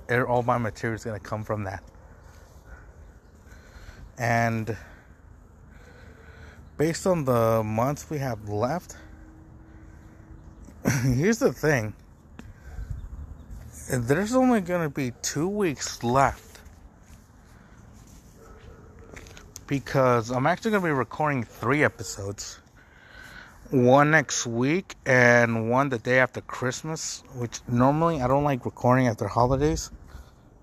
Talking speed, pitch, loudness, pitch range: 105 wpm, 115 Hz, -25 LUFS, 90-135 Hz